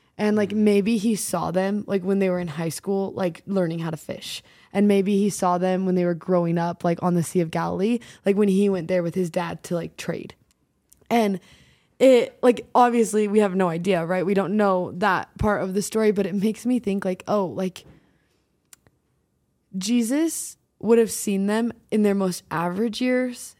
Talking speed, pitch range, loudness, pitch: 205 wpm, 180-215 Hz, -23 LUFS, 195 Hz